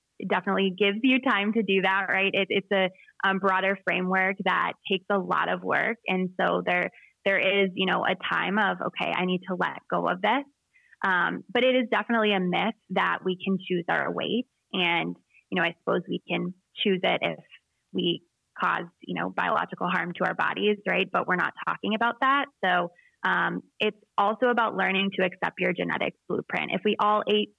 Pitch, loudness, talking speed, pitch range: 195 Hz, -26 LUFS, 200 wpm, 185-215 Hz